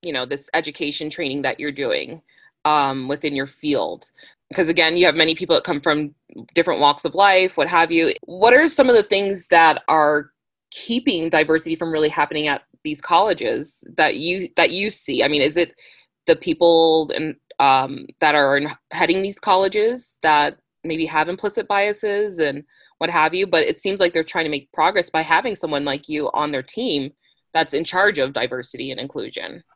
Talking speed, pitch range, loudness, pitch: 195 wpm, 150-195 Hz, -19 LUFS, 165 Hz